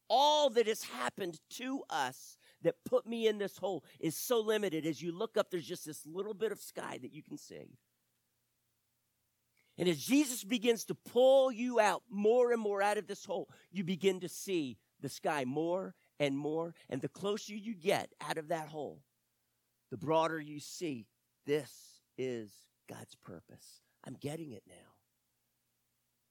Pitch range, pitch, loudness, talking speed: 140-220 Hz, 180 Hz, -35 LUFS, 170 wpm